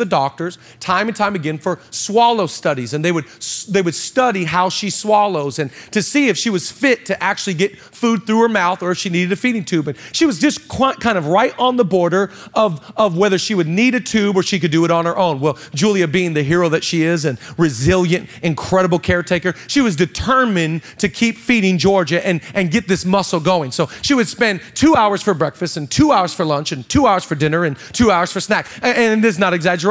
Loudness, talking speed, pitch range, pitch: -16 LUFS, 240 wpm, 170-215 Hz, 185 Hz